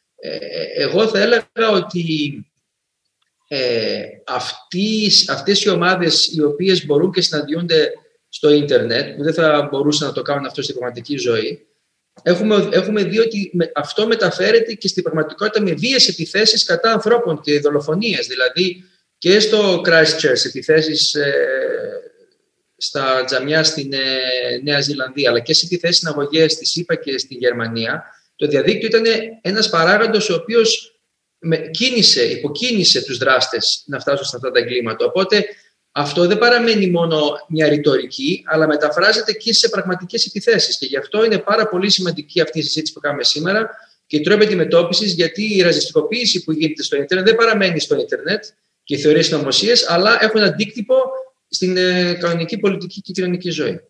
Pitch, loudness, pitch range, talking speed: 185 Hz, -16 LUFS, 155-225 Hz, 155 wpm